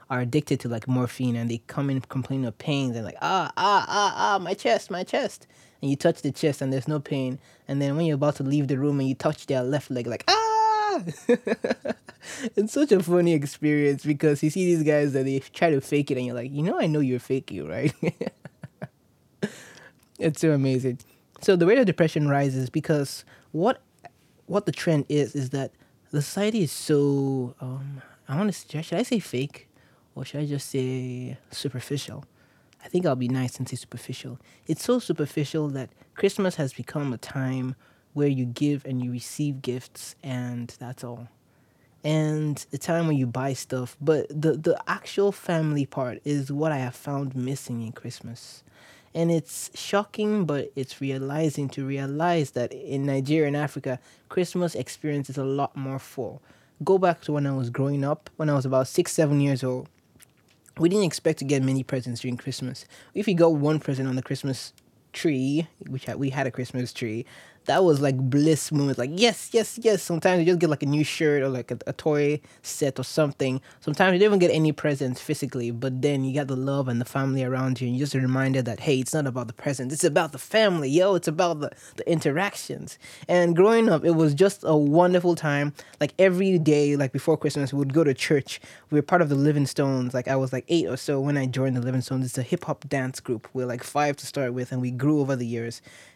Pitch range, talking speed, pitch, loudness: 130-155 Hz, 215 wpm, 140 Hz, -25 LUFS